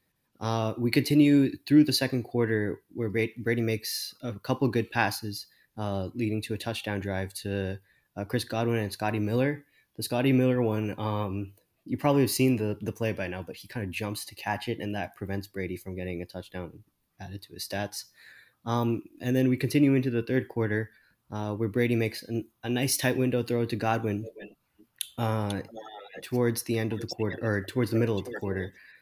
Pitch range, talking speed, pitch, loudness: 105-120 Hz, 200 wpm, 110 Hz, -29 LUFS